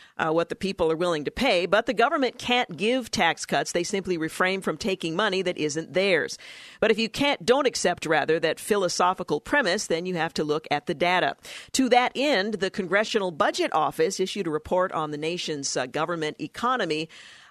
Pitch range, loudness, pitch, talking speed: 160-220 Hz, -25 LUFS, 185 Hz, 200 wpm